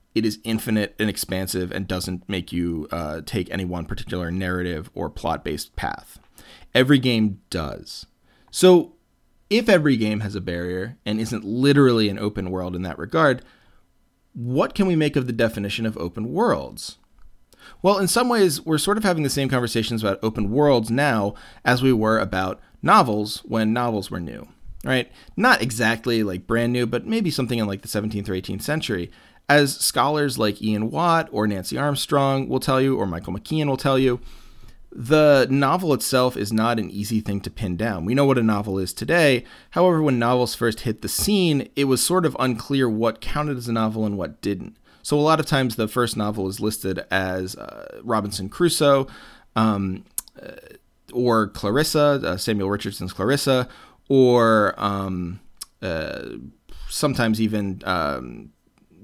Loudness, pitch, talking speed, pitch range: -22 LUFS, 115 Hz, 175 wpm, 100-135 Hz